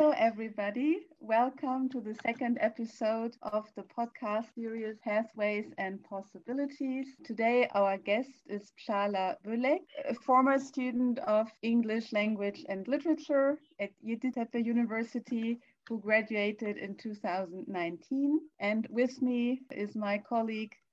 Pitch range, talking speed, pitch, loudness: 210-255 Hz, 120 wpm, 230 Hz, -33 LUFS